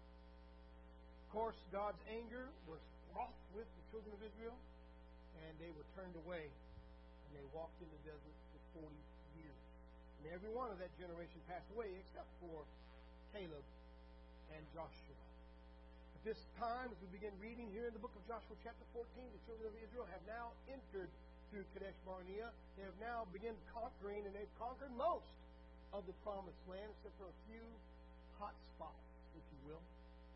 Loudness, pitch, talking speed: -53 LUFS, 175 Hz, 170 wpm